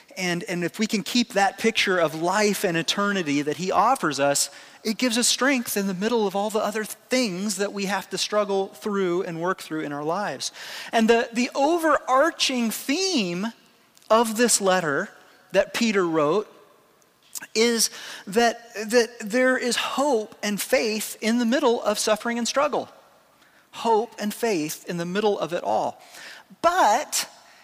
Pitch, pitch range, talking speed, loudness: 215 Hz, 195-240 Hz, 165 wpm, -23 LUFS